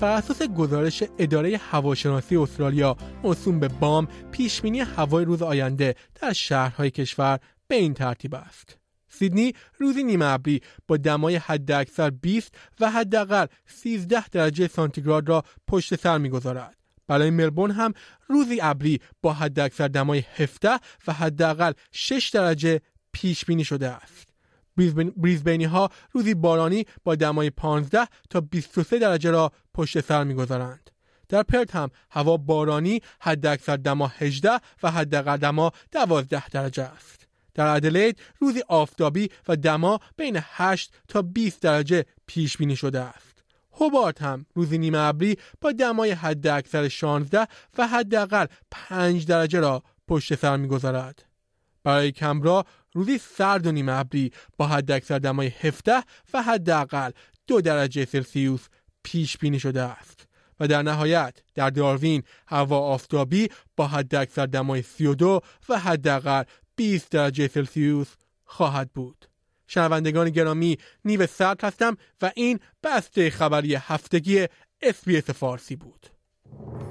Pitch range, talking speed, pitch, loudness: 140-185 Hz, 135 wpm, 155 Hz, -24 LUFS